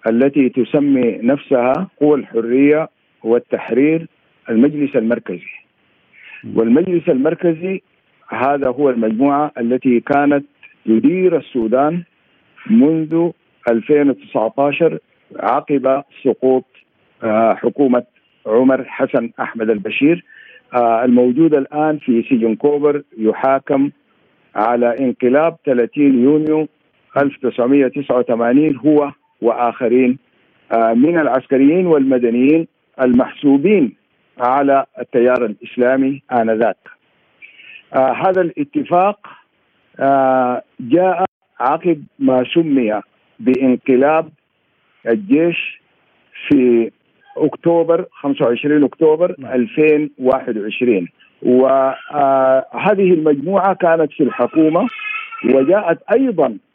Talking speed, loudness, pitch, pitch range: 75 wpm, -15 LUFS, 140 Hz, 125-160 Hz